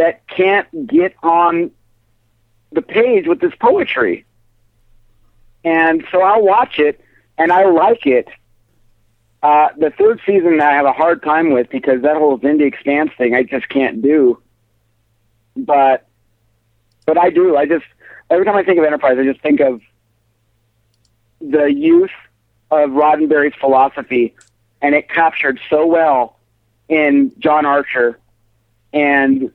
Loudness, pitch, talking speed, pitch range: -14 LUFS, 140 Hz, 140 wpm, 115-160 Hz